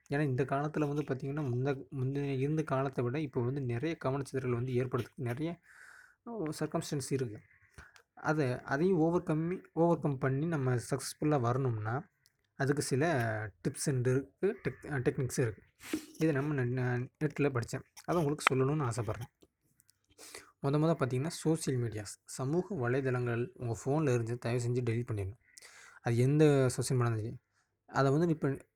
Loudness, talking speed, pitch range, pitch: -33 LUFS, 135 wpm, 125-150 Hz, 135 Hz